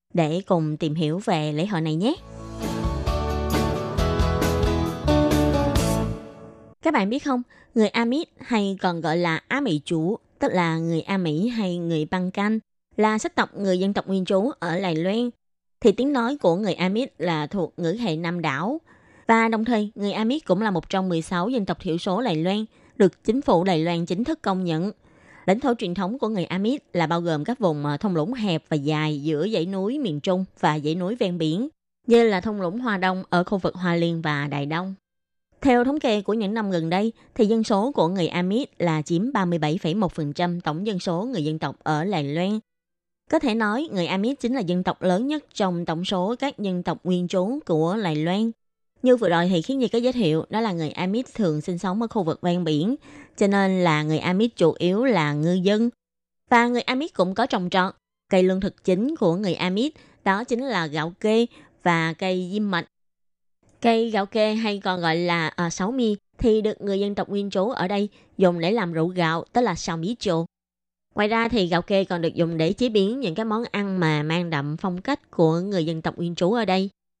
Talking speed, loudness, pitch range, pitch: 215 wpm, -23 LUFS, 165-220 Hz, 185 Hz